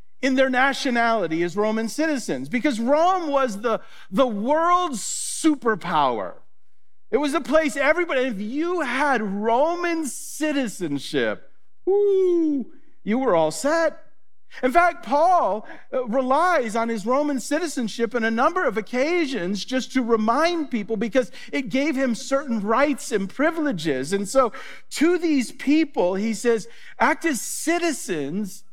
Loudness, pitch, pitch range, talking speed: -22 LUFS, 265 Hz, 230-315 Hz, 130 wpm